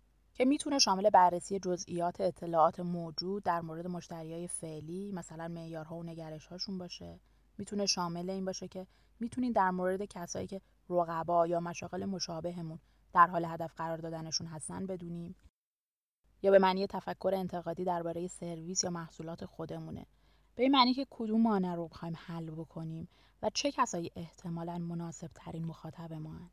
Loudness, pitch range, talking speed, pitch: -34 LUFS, 165-190 Hz, 150 wpm, 175 Hz